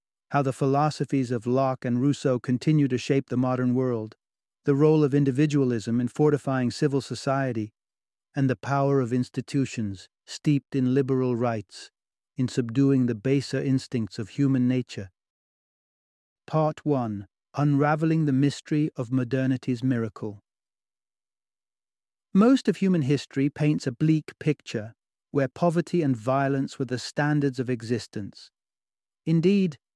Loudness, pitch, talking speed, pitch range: -25 LUFS, 135 Hz, 130 wpm, 125-145 Hz